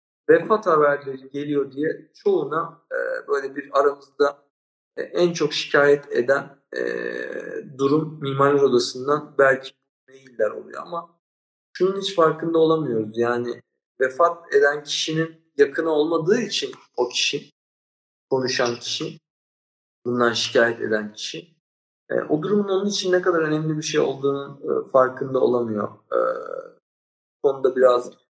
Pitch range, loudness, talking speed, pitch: 135-185 Hz, -22 LUFS, 125 wpm, 150 Hz